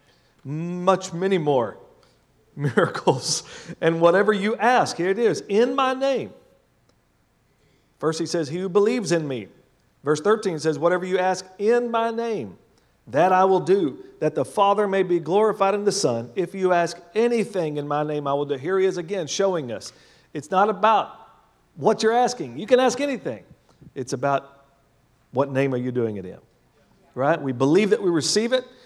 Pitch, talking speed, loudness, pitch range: 185 Hz, 180 wpm, -22 LUFS, 150-215 Hz